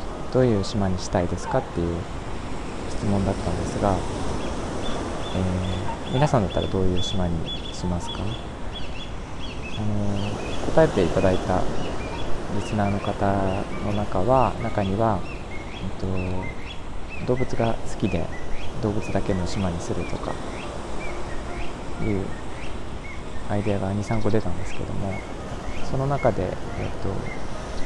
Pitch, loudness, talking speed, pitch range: 95 Hz, -27 LUFS, 240 characters per minute, 90-105 Hz